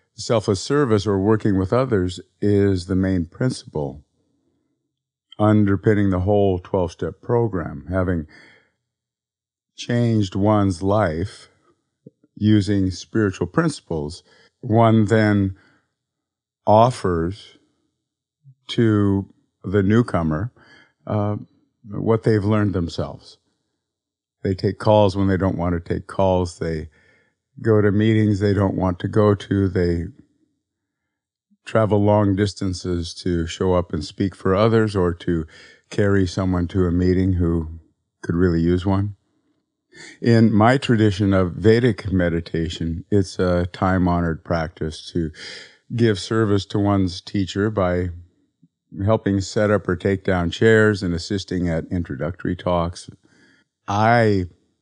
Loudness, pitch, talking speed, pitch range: -20 LUFS, 100 Hz, 115 wpm, 90-110 Hz